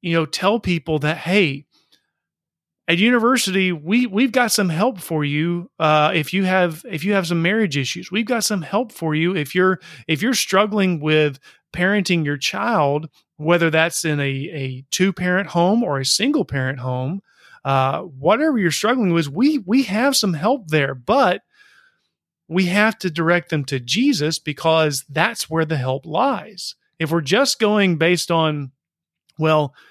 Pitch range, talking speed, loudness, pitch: 155-205 Hz, 170 wpm, -19 LUFS, 175 Hz